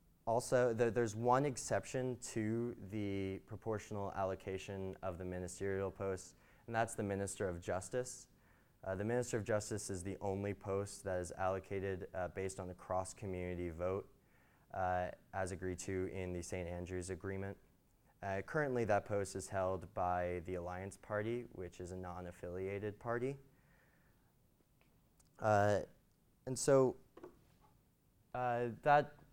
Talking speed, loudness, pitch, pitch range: 140 wpm, -40 LUFS, 100 Hz, 95-115 Hz